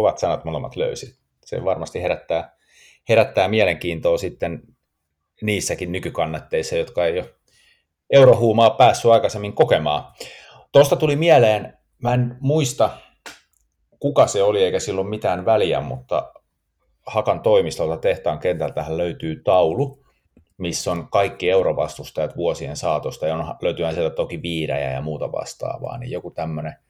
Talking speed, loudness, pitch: 125 wpm, -20 LUFS, 175 Hz